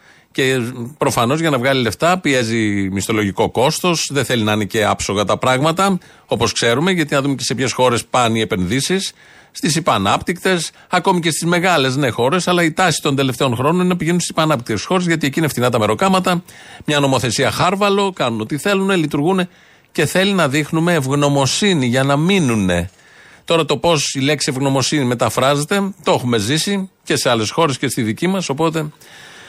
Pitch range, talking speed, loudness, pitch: 125-175 Hz, 180 wpm, -16 LUFS, 145 Hz